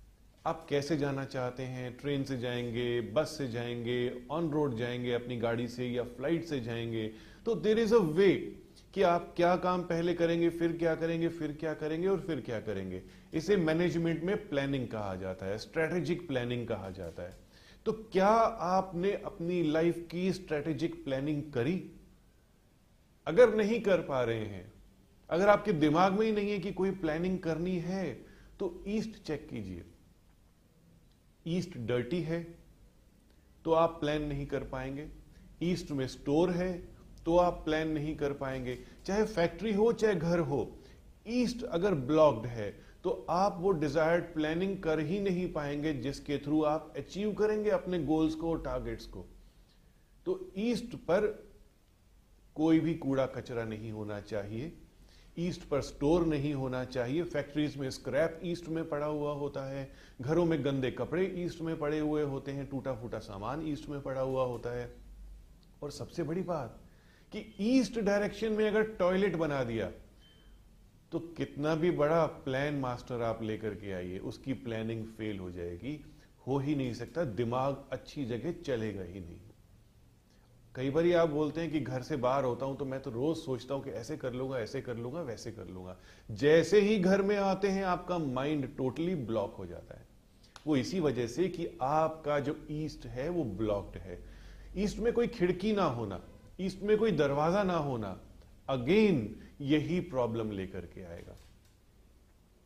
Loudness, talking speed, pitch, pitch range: -33 LUFS, 165 wpm, 150 Hz, 120-175 Hz